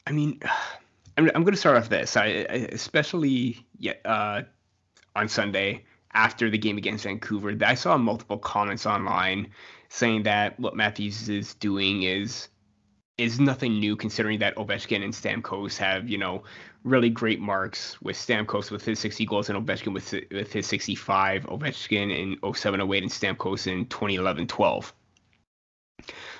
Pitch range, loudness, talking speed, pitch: 100-115 Hz, -26 LUFS, 150 wpm, 105 Hz